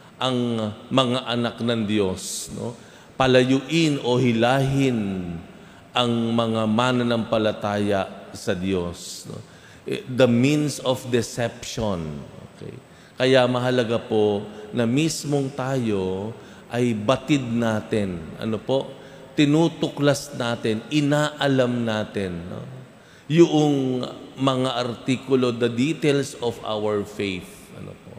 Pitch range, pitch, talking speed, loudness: 110-135 Hz, 120 Hz, 95 wpm, -23 LUFS